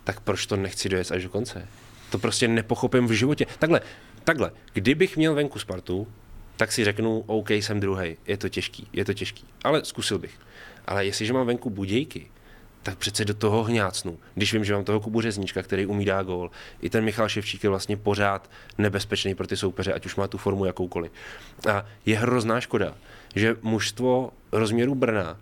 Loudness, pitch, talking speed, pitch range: -26 LUFS, 105 Hz, 185 wpm, 95-115 Hz